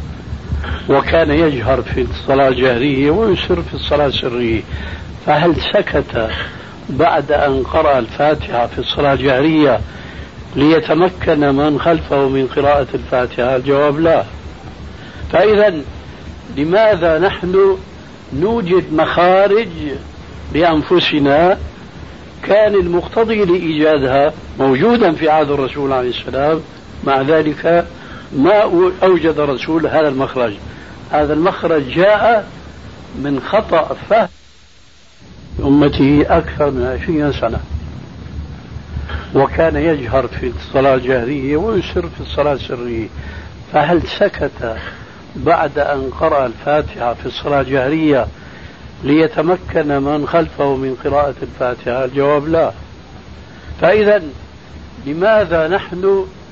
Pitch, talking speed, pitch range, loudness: 145 Hz, 95 wpm, 125-160 Hz, -14 LUFS